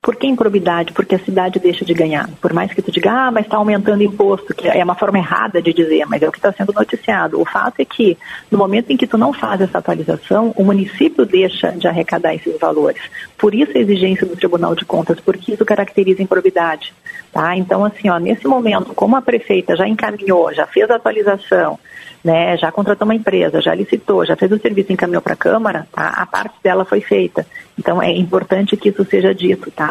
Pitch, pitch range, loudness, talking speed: 195 Hz, 180-215 Hz, -15 LUFS, 220 wpm